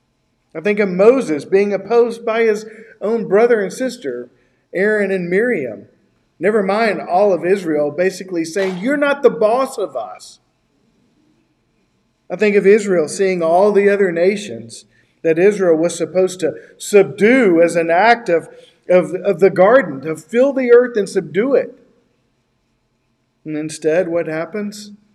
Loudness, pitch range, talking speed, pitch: -15 LUFS, 165-215 Hz, 150 wpm, 195 Hz